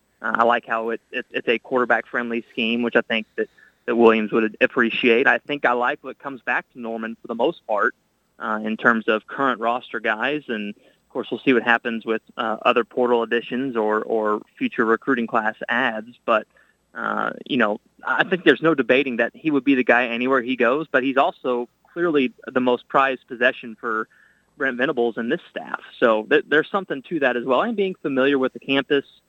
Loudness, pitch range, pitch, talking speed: -21 LUFS, 115-135 Hz, 120 Hz, 210 wpm